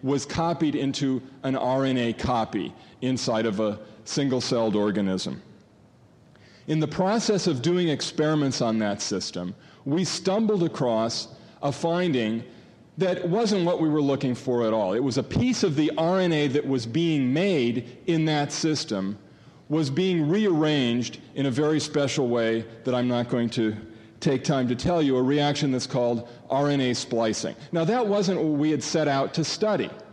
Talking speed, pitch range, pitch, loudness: 165 wpm, 120-160 Hz, 140 Hz, -25 LUFS